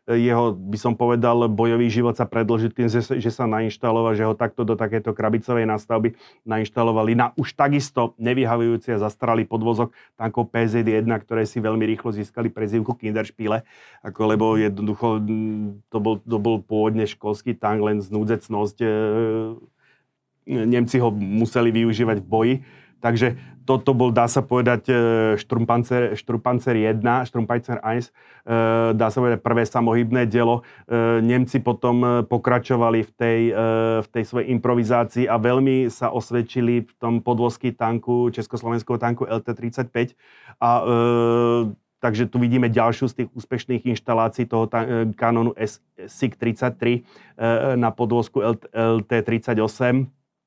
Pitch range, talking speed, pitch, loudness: 110-120 Hz, 125 wpm, 115 Hz, -21 LUFS